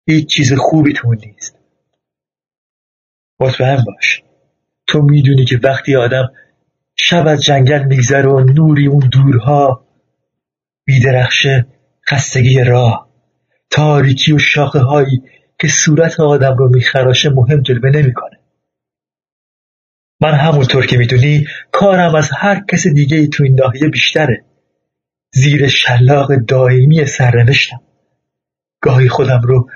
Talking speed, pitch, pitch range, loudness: 115 wpm, 135 Hz, 130-145 Hz, -10 LUFS